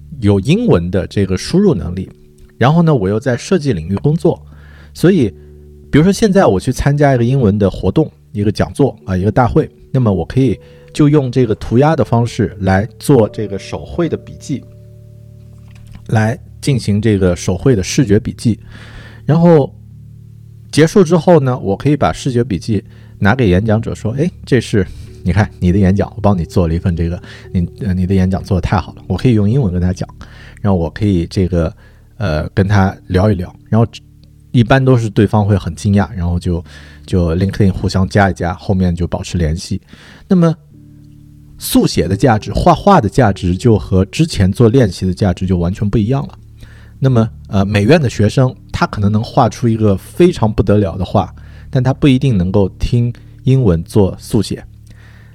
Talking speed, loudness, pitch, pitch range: 280 characters per minute, -14 LUFS, 105 Hz, 95-120 Hz